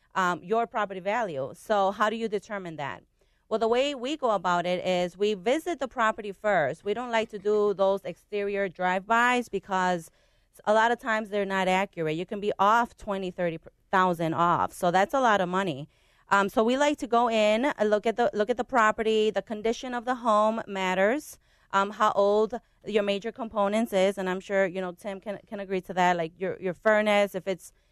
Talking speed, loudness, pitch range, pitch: 210 wpm, -26 LUFS, 185-225 Hz, 205 Hz